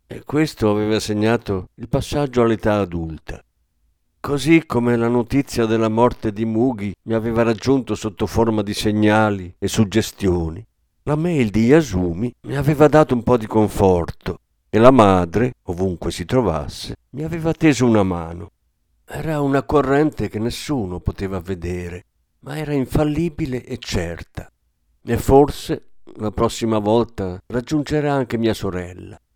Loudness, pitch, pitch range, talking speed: -19 LUFS, 110 Hz, 95-130 Hz, 140 wpm